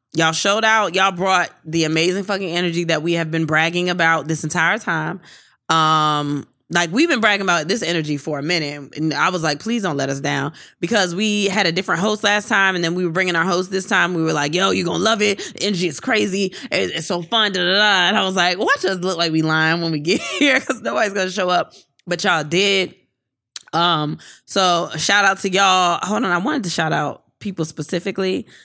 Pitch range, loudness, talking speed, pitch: 160-195 Hz, -18 LUFS, 235 wpm, 175 Hz